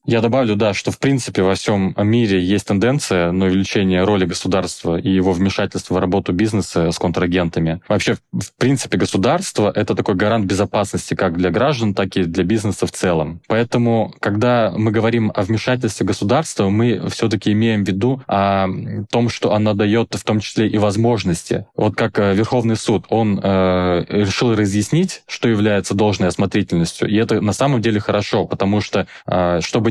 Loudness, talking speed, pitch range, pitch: -17 LUFS, 165 wpm, 95-115 Hz, 105 Hz